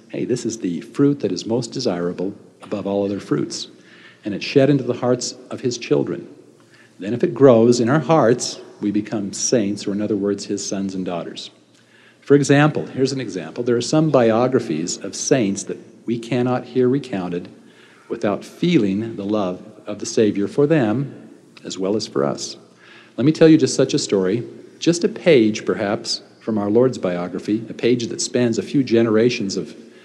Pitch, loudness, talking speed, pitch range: 115 Hz, -19 LUFS, 190 wpm, 100-130 Hz